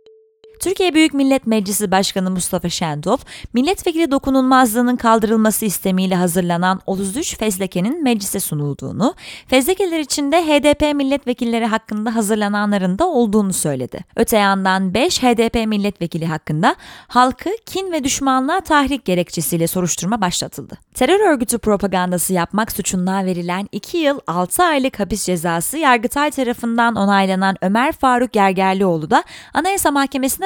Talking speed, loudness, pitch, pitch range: 120 wpm, -17 LUFS, 225 Hz, 190-275 Hz